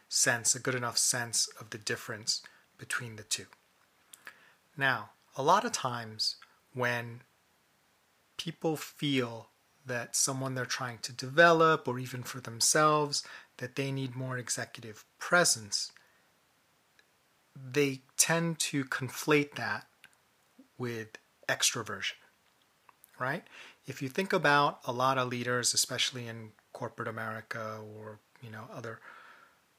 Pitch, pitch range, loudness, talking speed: 130 Hz, 120-145 Hz, -30 LUFS, 120 wpm